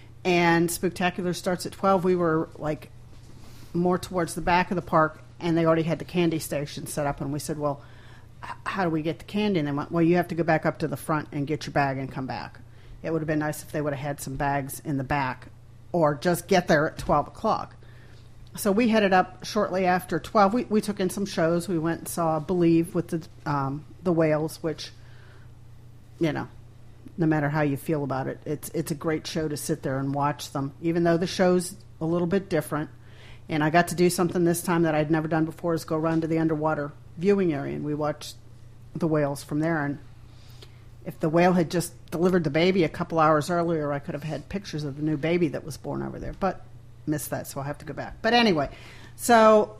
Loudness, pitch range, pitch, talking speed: -26 LUFS, 135-170 Hz, 155 Hz, 235 wpm